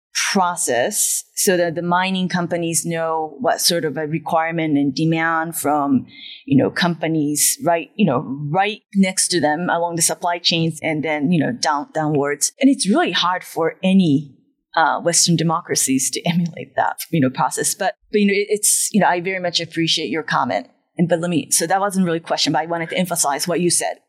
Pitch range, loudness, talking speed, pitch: 155-180 Hz, -18 LUFS, 205 wpm, 170 Hz